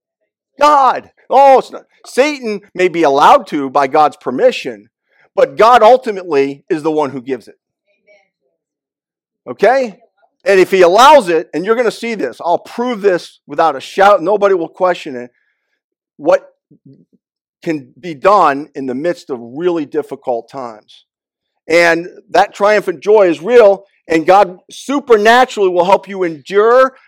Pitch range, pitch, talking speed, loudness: 165-250 Hz, 195 Hz, 150 wpm, -12 LUFS